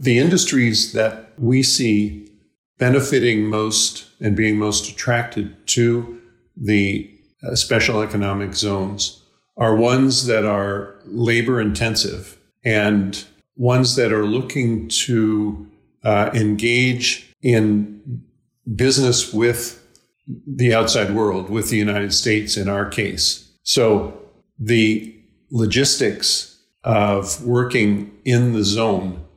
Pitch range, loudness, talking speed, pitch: 105-120 Hz, -18 LUFS, 105 wpm, 110 Hz